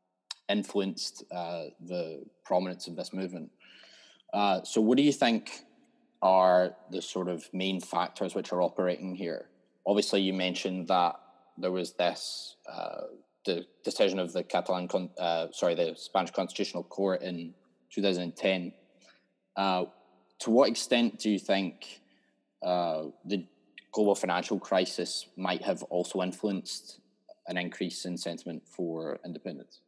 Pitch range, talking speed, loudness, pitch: 90-95 Hz, 135 wpm, -31 LUFS, 90 Hz